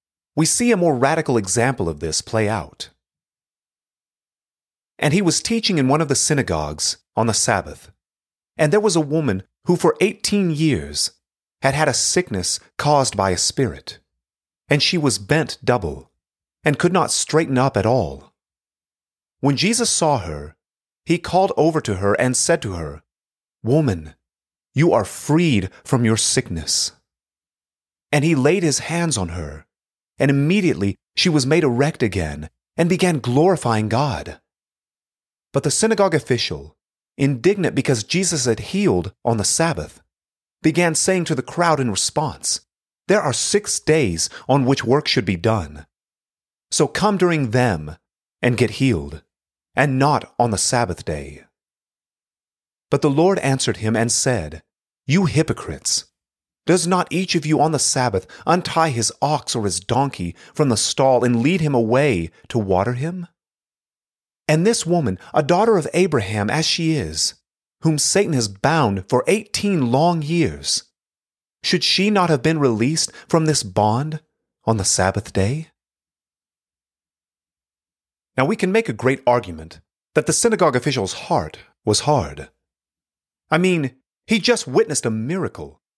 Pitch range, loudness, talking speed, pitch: 95-160 Hz, -19 LUFS, 150 wpm, 135 Hz